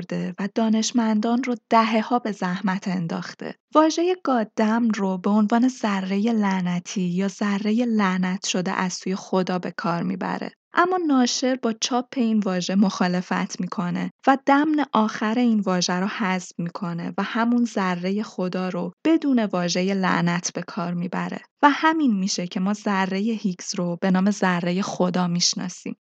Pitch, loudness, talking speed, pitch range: 200 Hz, -23 LUFS, 150 wpm, 185-230 Hz